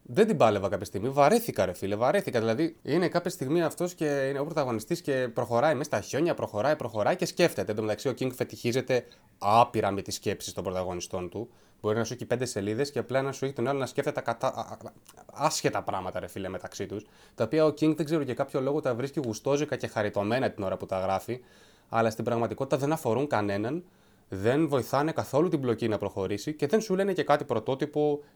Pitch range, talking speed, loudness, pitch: 110-150 Hz, 215 wpm, -29 LUFS, 130 Hz